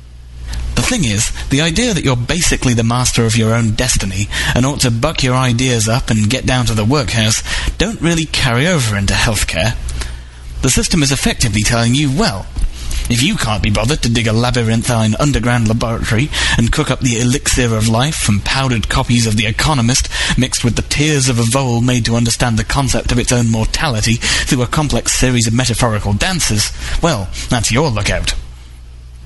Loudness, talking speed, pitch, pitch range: -14 LUFS, 185 wpm, 120 Hz, 110-130 Hz